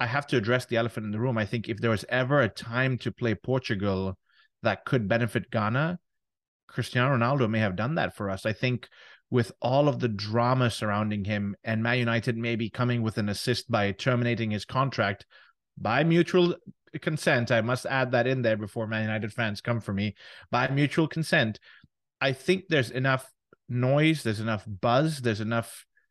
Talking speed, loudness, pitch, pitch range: 190 wpm, -27 LUFS, 120 Hz, 110-130 Hz